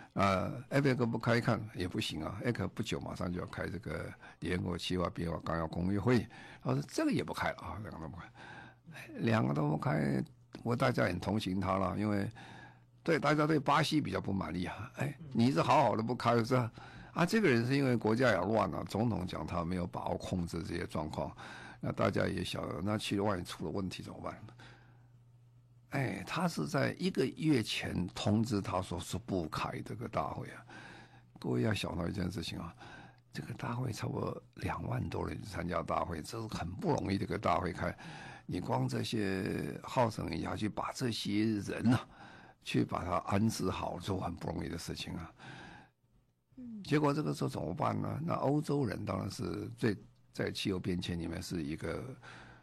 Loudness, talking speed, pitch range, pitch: -35 LUFS, 280 characters per minute, 90-125 Hz, 105 Hz